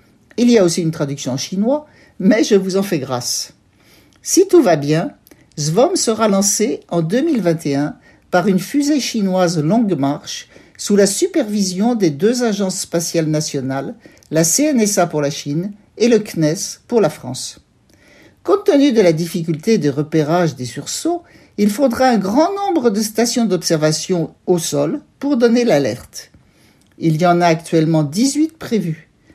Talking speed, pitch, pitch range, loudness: 155 wpm, 185 Hz, 155-230 Hz, -16 LUFS